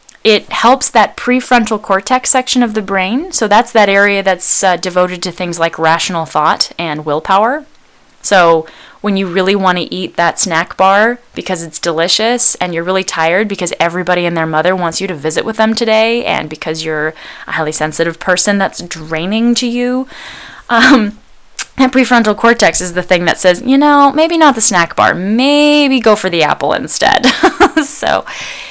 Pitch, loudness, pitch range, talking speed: 195 Hz, -11 LUFS, 170-240 Hz, 180 wpm